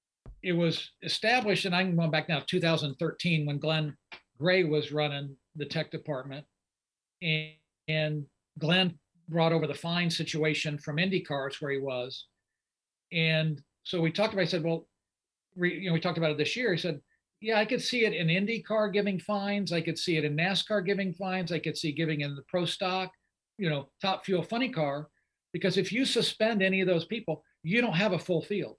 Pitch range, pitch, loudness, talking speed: 155-185 Hz, 165 Hz, -29 LUFS, 195 wpm